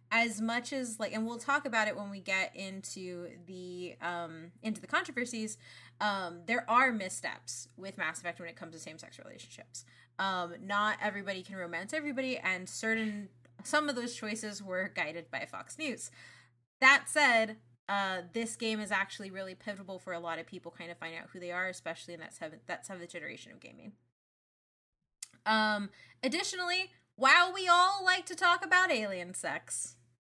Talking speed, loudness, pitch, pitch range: 175 wpm, -32 LUFS, 195 Hz, 175-235 Hz